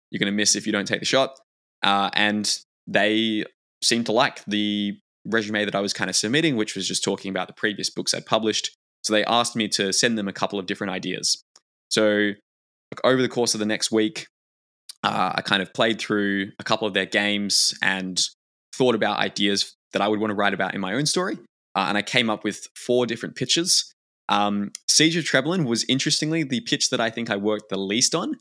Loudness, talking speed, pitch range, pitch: -22 LUFS, 220 wpm, 100-120 Hz, 105 Hz